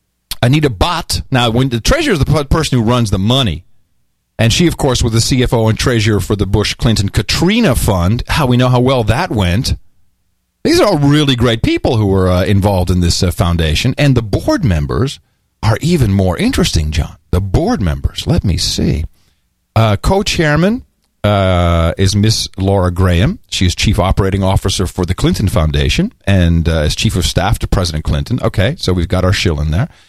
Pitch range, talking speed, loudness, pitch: 90-120 Hz, 195 wpm, -13 LUFS, 100 Hz